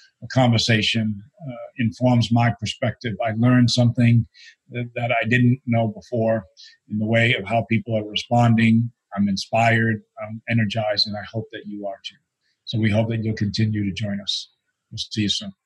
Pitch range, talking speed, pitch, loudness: 110-120 Hz, 180 wpm, 115 Hz, -21 LUFS